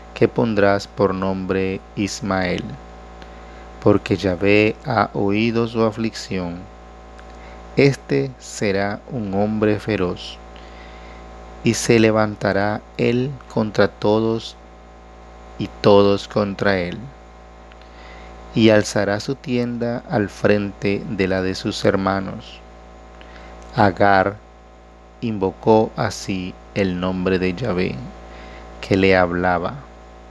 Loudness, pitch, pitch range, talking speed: -20 LUFS, 100 Hz, 95-110 Hz, 95 wpm